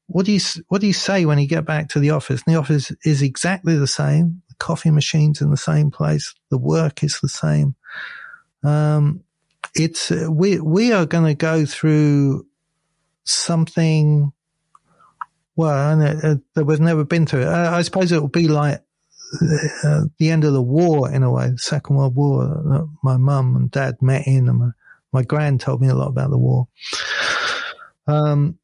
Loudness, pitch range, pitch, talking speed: -18 LUFS, 140-160 Hz, 150 Hz, 195 wpm